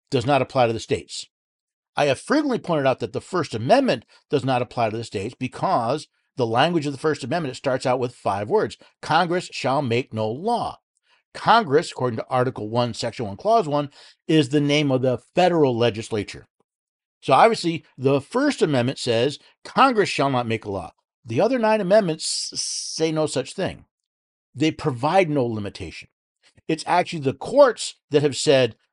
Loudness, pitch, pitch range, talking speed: -22 LUFS, 135 Hz, 120-160 Hz, 185 wpm